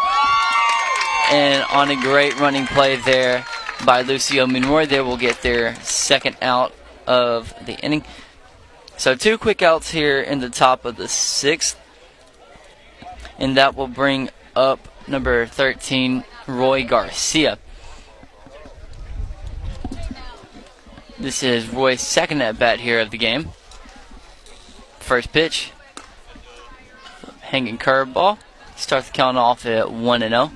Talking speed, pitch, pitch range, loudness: 120 wpm, 130 Hz, 120-140 Hz, -18 LUFS